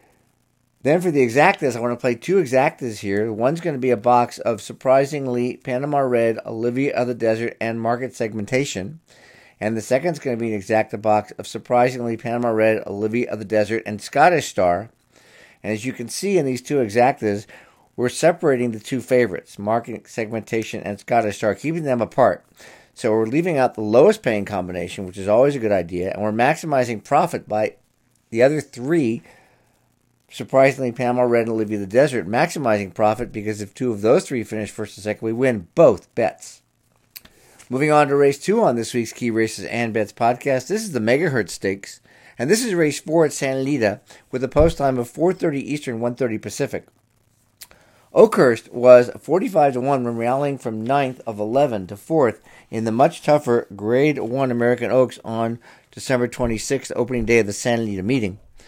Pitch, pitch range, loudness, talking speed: 120 Hz, 110-130 Hz, -20 LUFS, 190 wpm